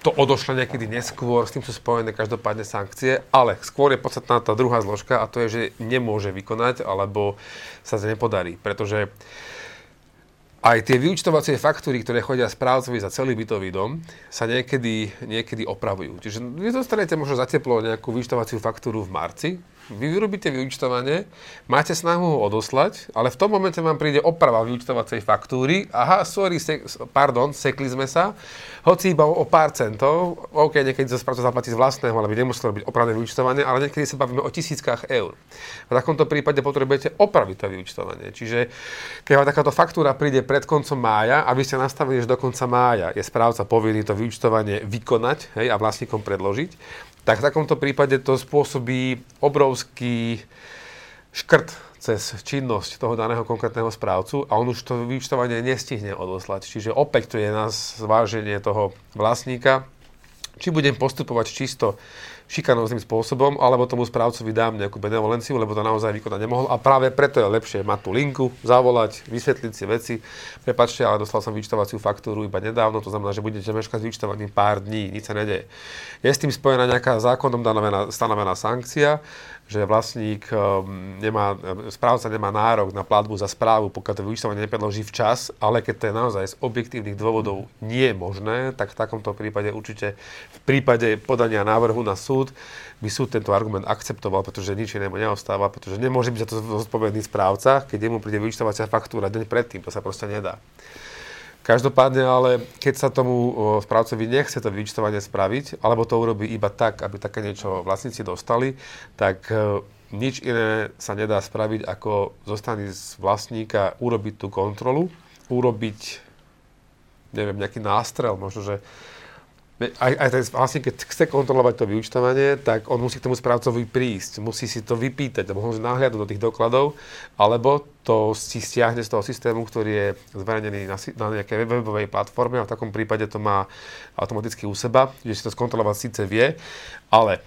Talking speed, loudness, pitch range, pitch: 165 wpm, -22 LUFS, 105-130 Hz, 115 Hz